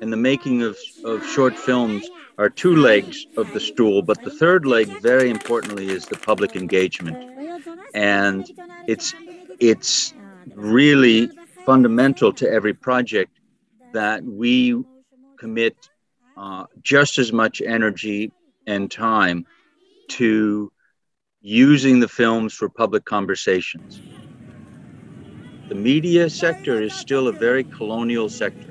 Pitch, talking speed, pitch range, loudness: 125 Hz, 120 wpm, 110-185 Hz, -19 LUFS